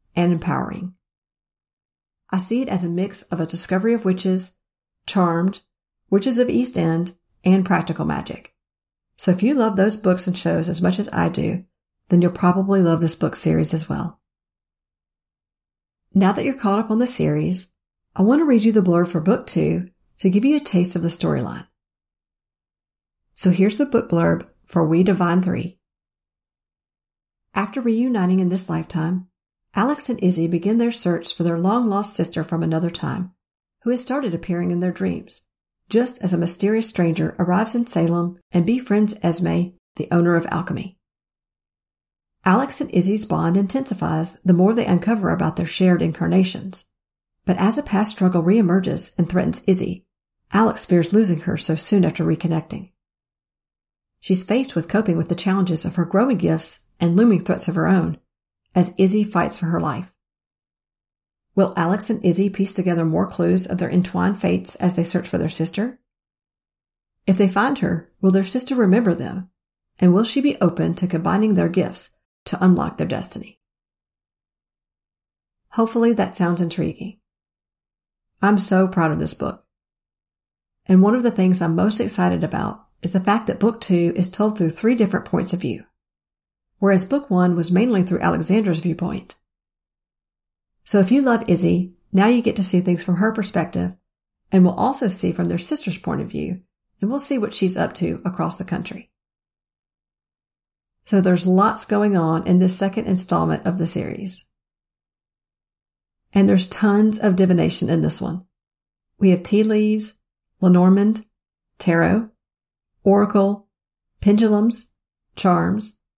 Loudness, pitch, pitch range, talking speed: -19 LUFS, 185 Hz, 170-205 Hz, 165 wpm